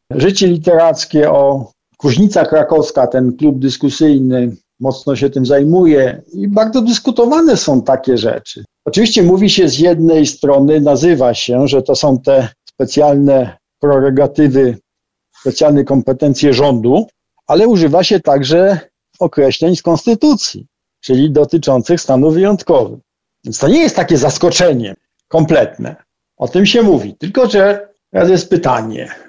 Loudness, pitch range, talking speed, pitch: -11 LUFS, 135-180 Hz, 125 wpm, 150 Hz